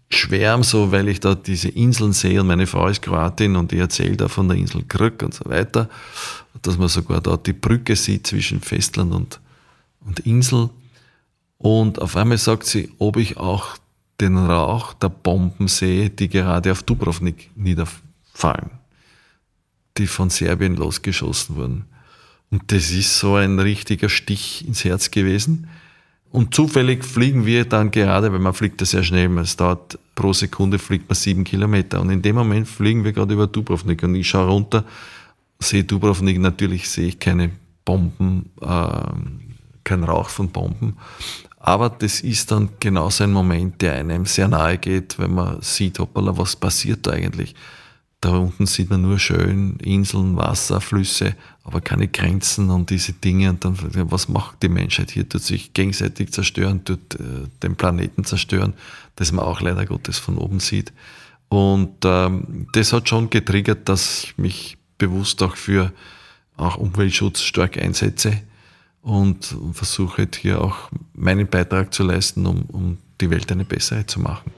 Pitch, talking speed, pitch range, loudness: 95 Hz, 165 wpm, 90-105 Hz, -19 LUFS